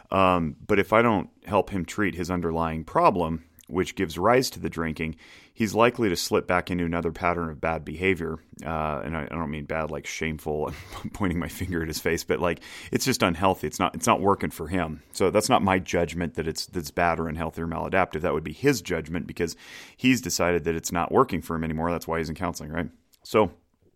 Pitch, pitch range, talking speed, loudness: 85 Hz, 80-90 Hz, 230 wpm, -26 LUFS